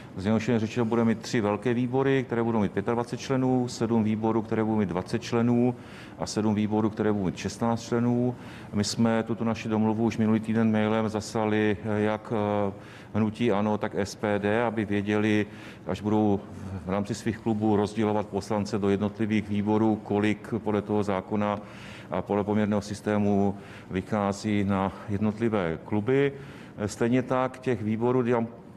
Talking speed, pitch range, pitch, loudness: 150 wpm, 105-115 Hz, 110 Hz, -27 LUFS